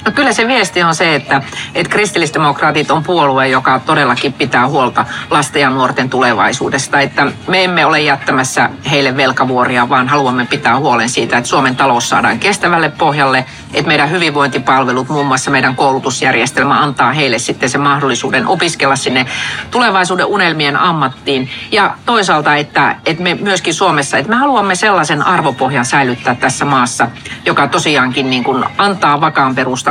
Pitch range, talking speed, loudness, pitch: 130-170 Hz, 155 wpm, -11 LUFS, 145 Hz